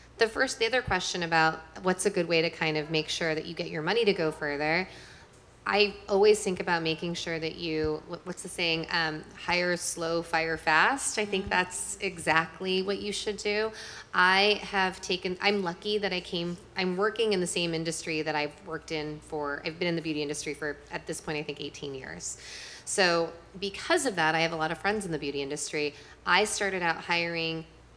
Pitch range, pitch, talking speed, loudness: 160-195 Hz, 170 Hz, 210 wpm, -28 LUFS